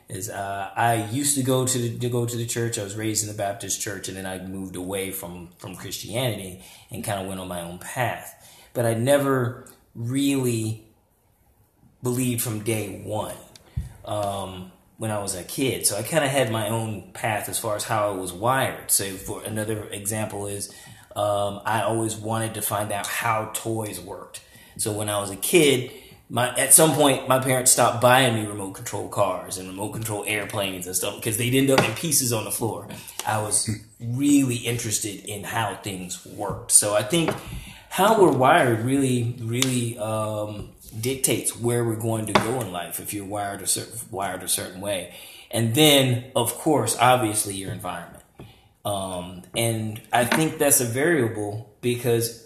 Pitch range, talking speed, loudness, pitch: 100-120 Hz, 185 wpm, -23 LUFS, 110 Hz